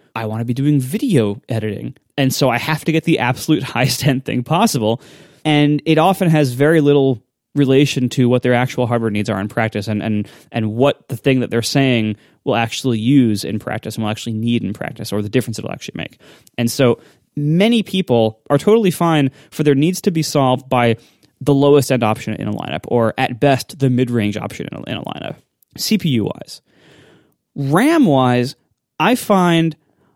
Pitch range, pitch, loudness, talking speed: 115-145 Hz, 130 Hz, -17 LUFS, 200 wpm